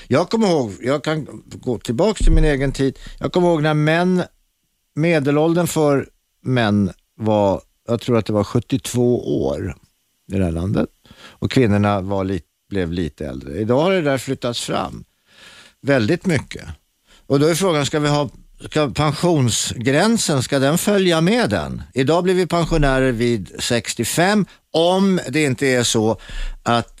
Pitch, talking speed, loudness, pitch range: 135 Hz, 160 wpm, -19 LUFS, 110-160 Hz